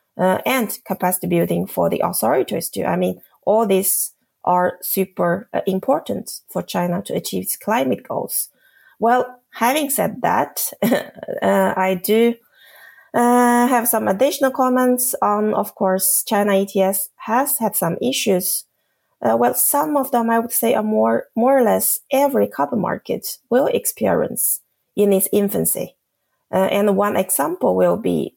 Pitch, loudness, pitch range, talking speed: 205 Hz, -18 LUFS, 185-245 Hz, 150 wpm